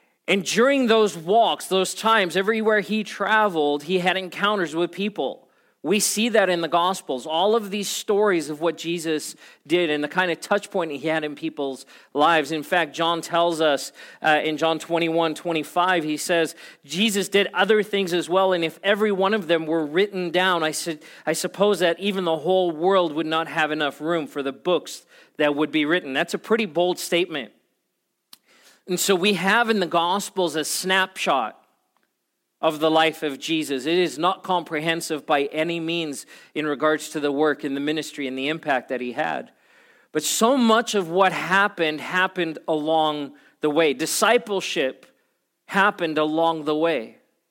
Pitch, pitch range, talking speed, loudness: 170 Hz, 155-195 Hz, 180 wpm, -22 LUFS